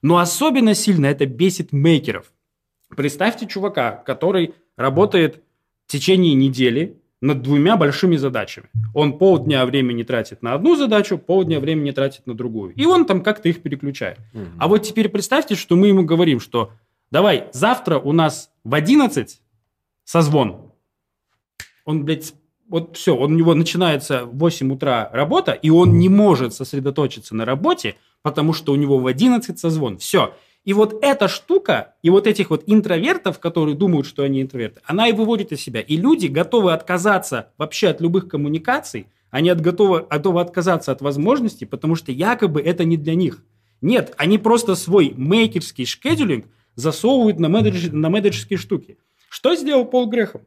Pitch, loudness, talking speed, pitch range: 165 Hz, -18 LUFS, 160 wpm, 135-195 Hz